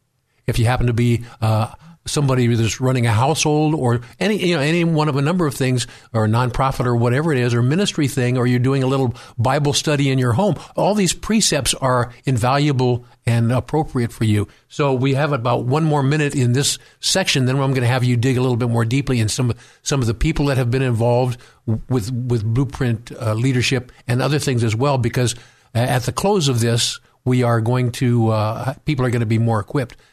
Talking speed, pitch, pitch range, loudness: 225 wpm, 125 Hz, 120-140 Hz, -19 LUFS